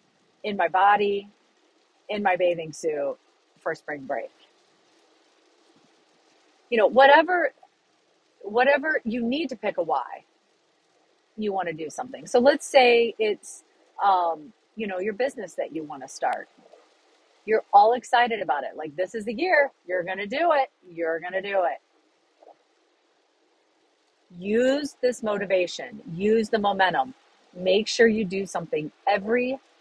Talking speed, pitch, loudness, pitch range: 140 wpm, 235 Hz, -24 LUFS, 195-310 Hz